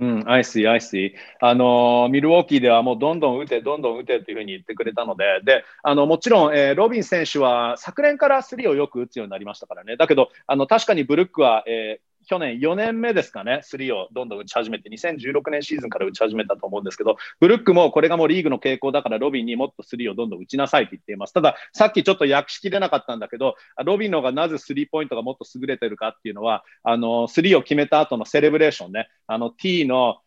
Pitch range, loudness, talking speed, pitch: 120-170 Hz, -20 LUFS, 500 characters per minute, 140 Hz